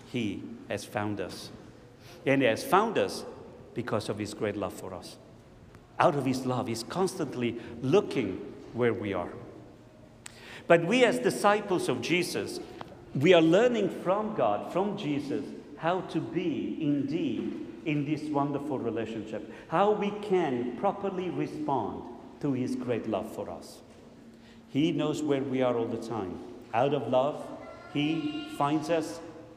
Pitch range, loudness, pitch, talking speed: 120-185 Hz, -29 LUFS, 150 Hz, 145 wpm